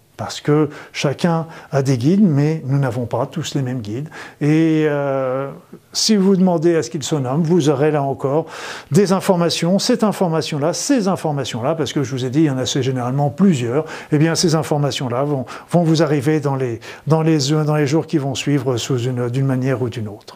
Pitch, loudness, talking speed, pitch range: 150 Hz, -18 LUFS, 210 wpm, 135-165 Hz